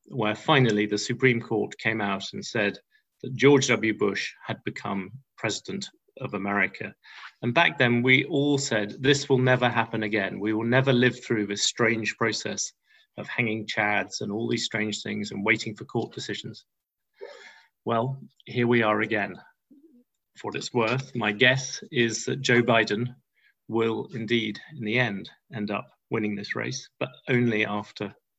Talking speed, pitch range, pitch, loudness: 165 wpm, 105-130 Hz, 115 Hz, -25 LUFS